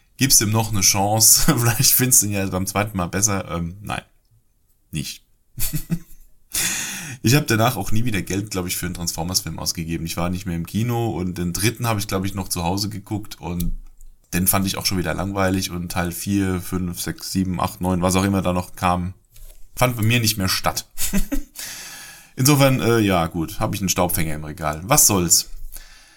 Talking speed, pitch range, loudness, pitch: 200 wpm, 90-115 Hz, -20 LUFS, 95 Hz